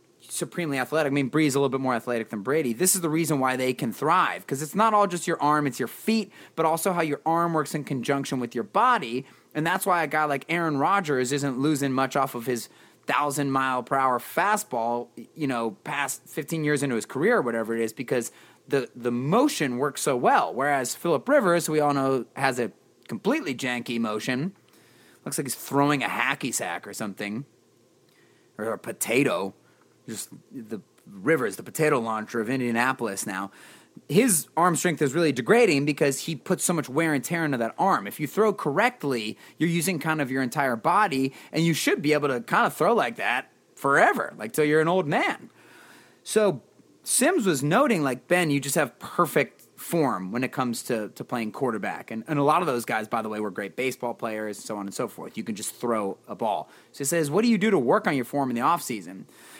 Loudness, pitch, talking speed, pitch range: -25 LUFS, 140 Hz, 220 wpm, 125-160 Hz